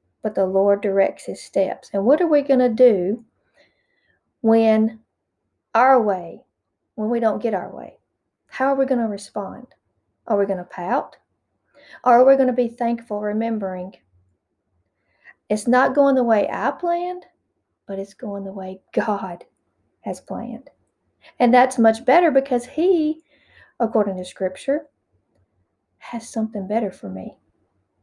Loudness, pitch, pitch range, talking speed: -20 LUFS, 225 Hz, 195-255 Hz, 150 wpm